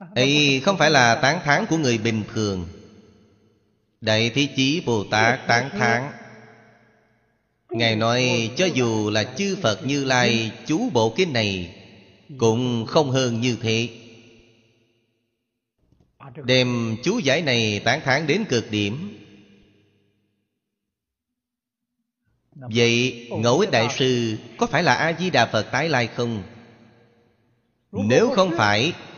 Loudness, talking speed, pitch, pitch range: -21 LUFS, 125 wpm, 115 Hz, 110-130 Hz